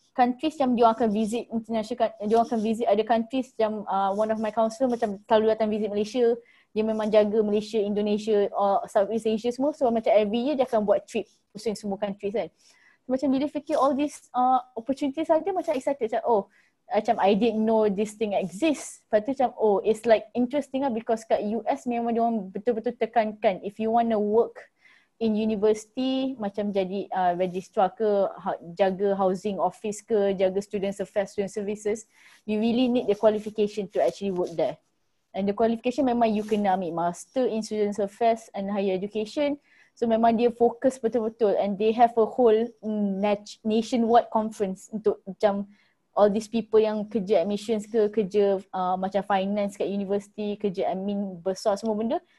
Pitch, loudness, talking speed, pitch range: 220 Hz, -26 LUFS, 180 wpm, 205-235 Hz